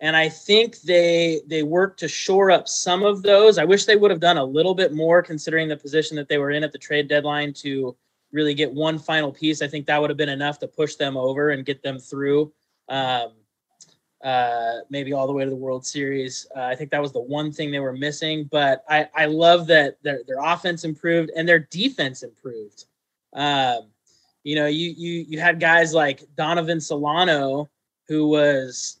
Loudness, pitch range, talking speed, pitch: -21 LUFS, 140-170 Hz, 210 wpm, 150 Hz